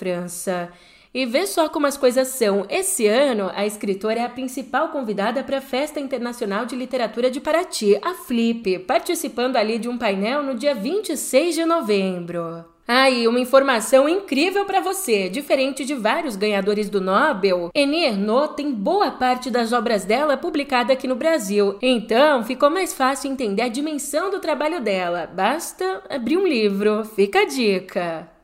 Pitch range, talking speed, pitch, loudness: 210-290 Hz, 160 wpm, 255 Hz, -21 LUFS